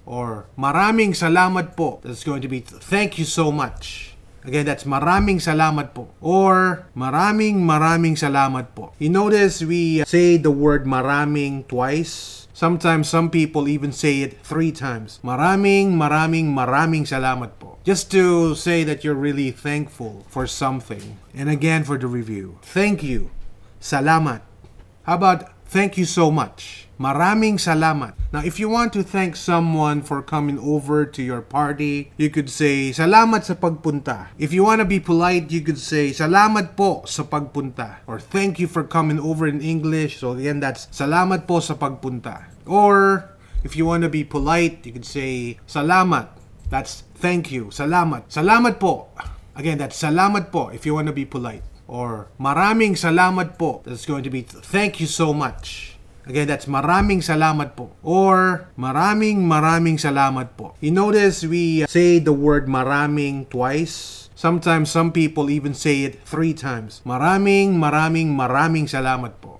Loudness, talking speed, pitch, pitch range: -19 LUFS, 160 wpm, 150 Hz, 130-170 Hz